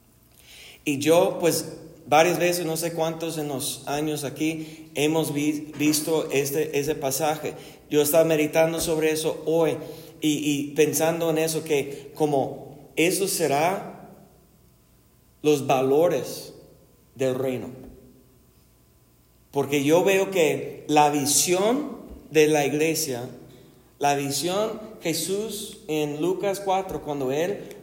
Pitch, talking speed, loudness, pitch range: 155 Hz, 115 wpm, -24 LUFS, 140-165 Hz